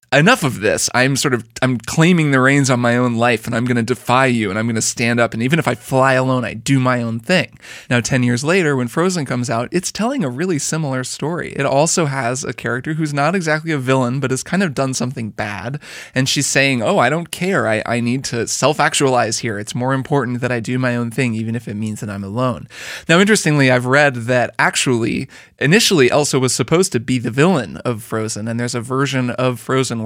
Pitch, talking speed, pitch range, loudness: 130 Hz, 235 wpm, 120-145 Hz, -17 LUFS